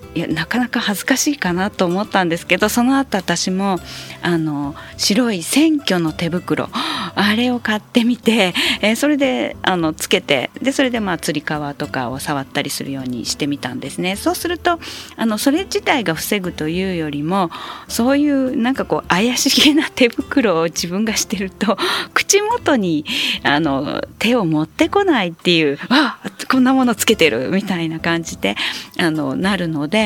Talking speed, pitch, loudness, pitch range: 330 characters per minute, 205 Hz, -17 LUFS, 165-260 Hz